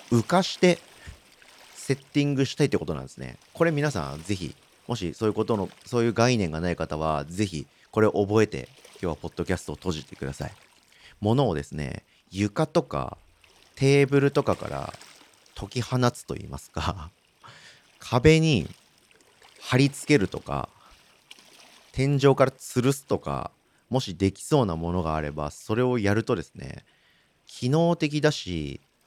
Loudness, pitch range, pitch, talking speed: -26 LUFS, 85-140 Hz, 110 Hz, 300 characters per minute